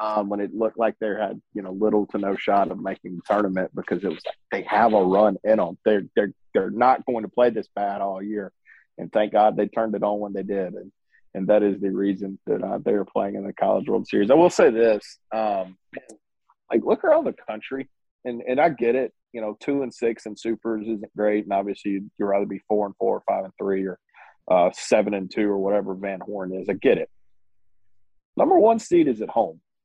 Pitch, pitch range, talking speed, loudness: 100 Hz, 100-110 Hz, 240 wpm, -23 LUFS